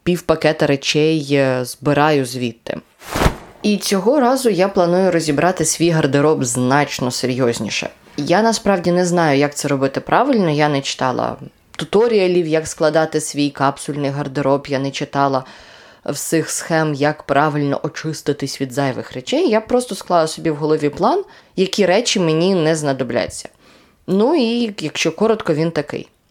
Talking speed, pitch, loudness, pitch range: 135 wpm, 155 Hz, -17 LUFS, 140-180 Hz